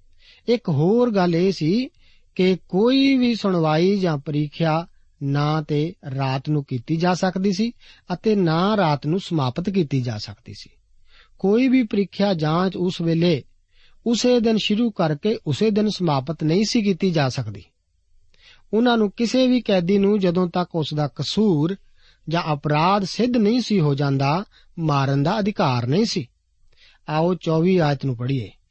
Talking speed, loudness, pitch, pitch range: 155 wpm, -21 LUFS, 170 Hz, 145-205 Hz